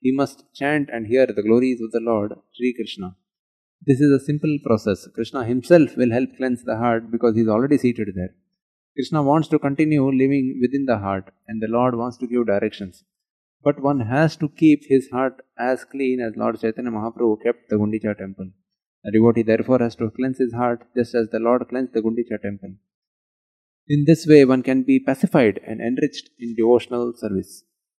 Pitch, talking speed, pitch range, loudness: 120 Hz, 195 wpm, 110-135 Hz, -20 LUFS